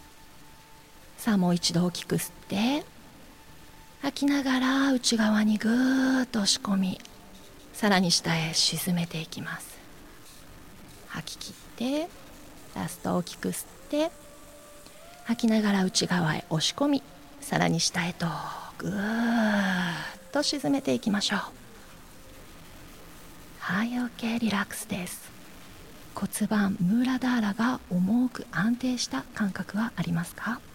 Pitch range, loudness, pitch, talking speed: 180-250 Hz, -27 LUFS, 215 Hz, 230 characters per minute